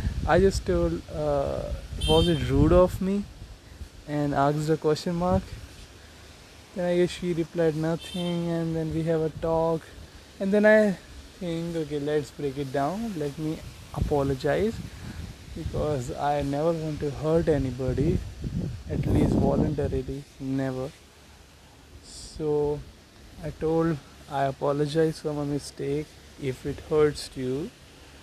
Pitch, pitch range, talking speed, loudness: 145 Hz, 125-165 Hz, 130 wpm, -27 LUFS